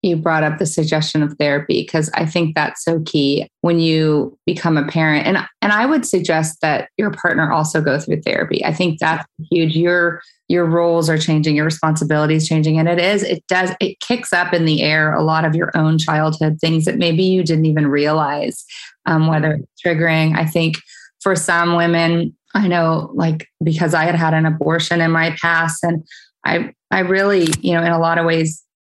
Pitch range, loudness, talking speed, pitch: 155-175 Hz, -16 LUFS, 205 wpm, 165 Hz